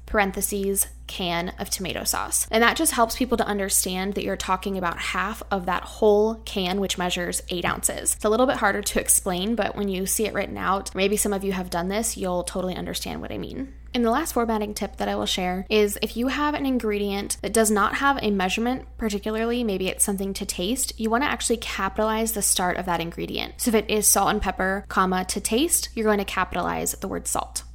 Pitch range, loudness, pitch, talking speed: 190-225 Hz, -24 LUFS, 205 Hz, 225 wpm